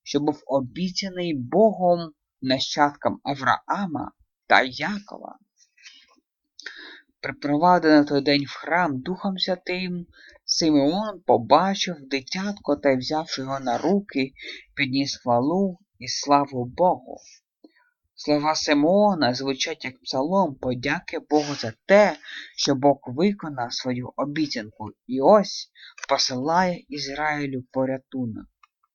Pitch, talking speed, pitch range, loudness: 150 Hz, 95 wpm, 135-180 Hz, -23 LUFS